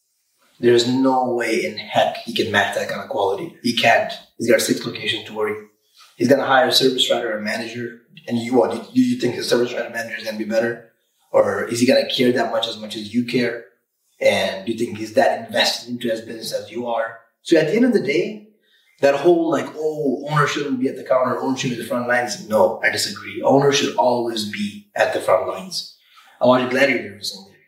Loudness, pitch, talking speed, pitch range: -19 LUFS, 120 Hz, 240 wpm, 115-140 Hz